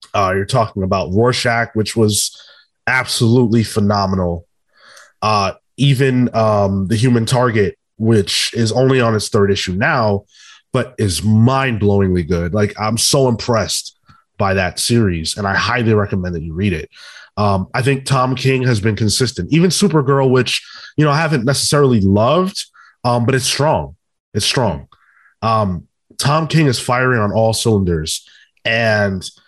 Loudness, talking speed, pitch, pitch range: -15 LUFS, 155 wpm, 110 Hz, 100-130 Hz